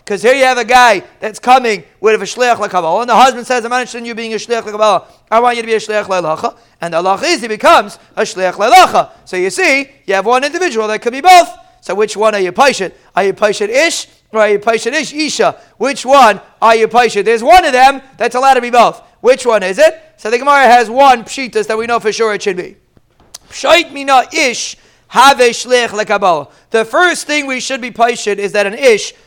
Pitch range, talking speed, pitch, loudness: 215-280 Hz, 230 wpm, 245 Hz, -11 LUFS